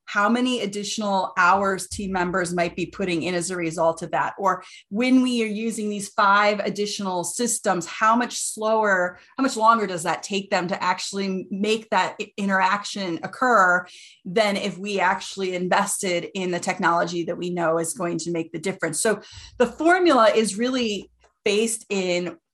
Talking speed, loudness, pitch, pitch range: 170 wpm, -23 LUFS, 195 Hz, 180-215 Hz